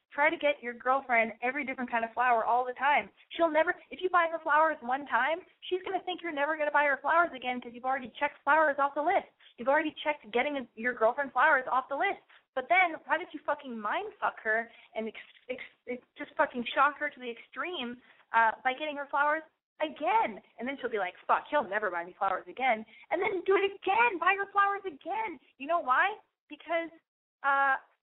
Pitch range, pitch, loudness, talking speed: 250-335 Hz, 290 Hz, -30 LUFS, 225 wpm